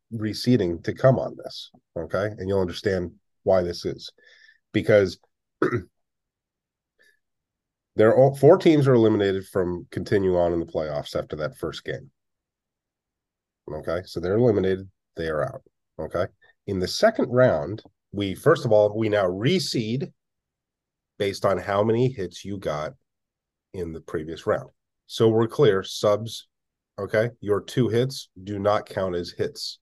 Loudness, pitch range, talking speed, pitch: -23 LUFS, 95-125 Hz, 145 wpm, 105 Hz